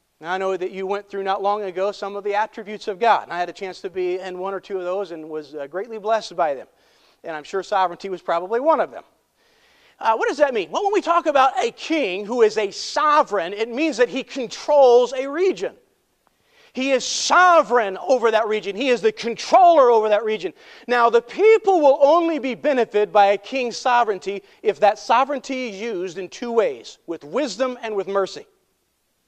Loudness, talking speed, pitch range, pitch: -20 LUFS, 215 wpm, 195-270 Hz, 220 Hz